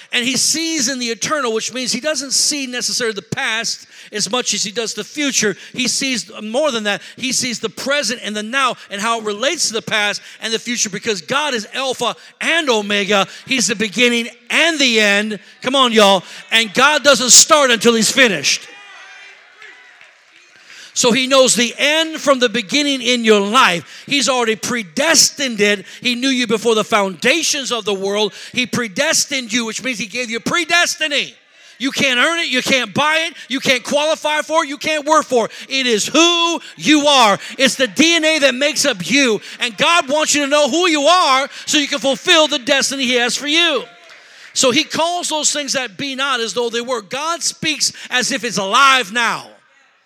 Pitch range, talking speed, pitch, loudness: 230-290 Hz, 200 wpm, 255 Hz, -15 LUFS